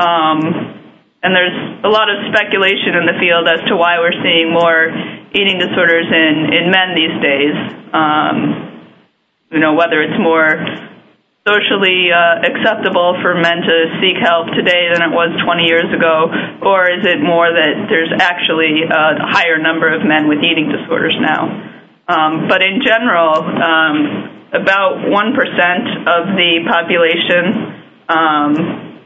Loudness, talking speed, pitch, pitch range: -12 LUFS, 145 wpm, 170 Hz, 160-190 Hz